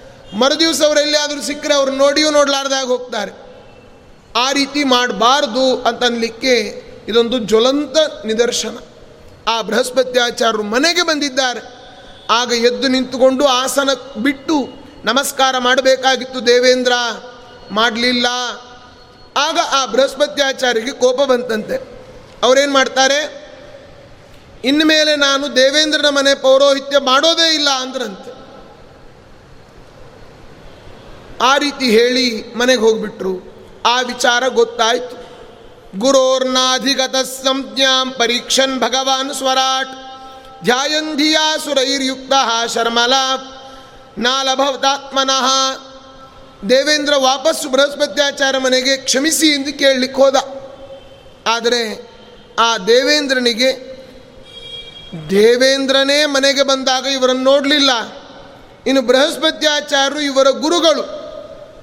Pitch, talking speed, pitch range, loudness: 265 Hz, 80 wpm, 245-280 Hz, -14 LUFS